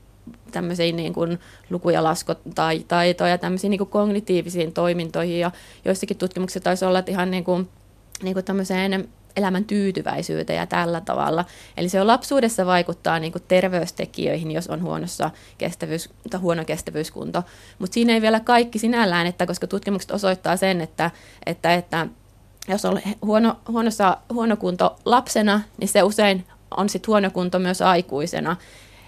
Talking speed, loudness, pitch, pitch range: 140 wpm, -22 LUFS, 185 Hz, 170-200 Hz